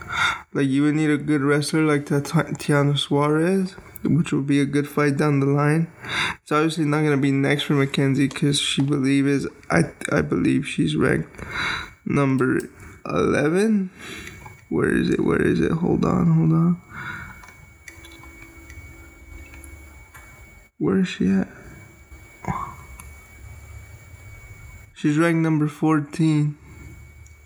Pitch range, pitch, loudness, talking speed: 115-155 Hz, 145 Hz, -21 LUFS, 120 wpm